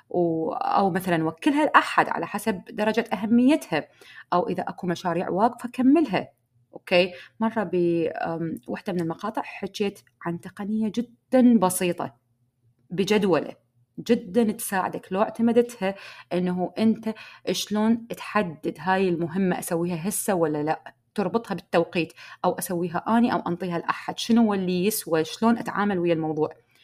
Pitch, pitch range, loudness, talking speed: 190 Hz, 170-220 Hz, -25 LUFS, 120 wpm